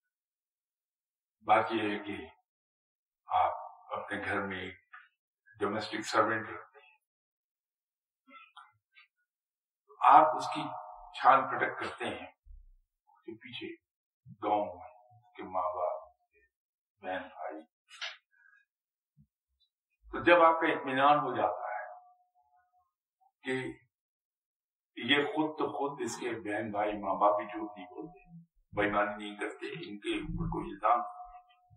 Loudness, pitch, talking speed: -31 LUFS, 155 Hz, 105 wpm